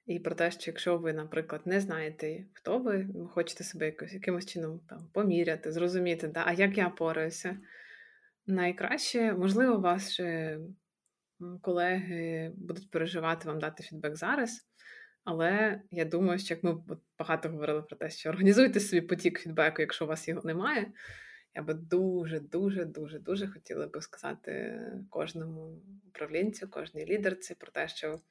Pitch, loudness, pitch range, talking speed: 175 Hz, -32 LUFS, 160-190 Hz, 150 wpm